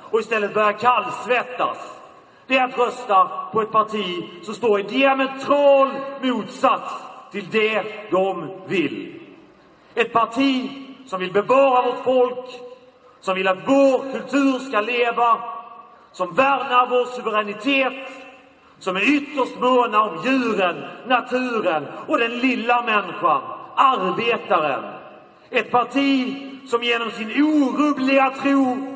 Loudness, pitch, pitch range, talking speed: -20 LUFS, 250 Hz, 225-270 Hz, 120 wpm